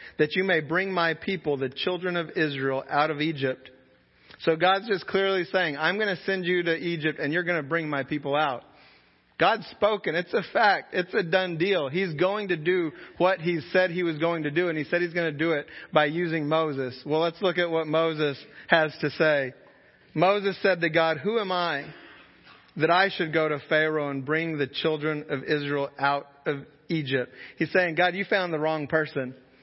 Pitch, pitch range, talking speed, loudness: 160 Hz, 150-180 Hz, 210 wpm, -26 LUFS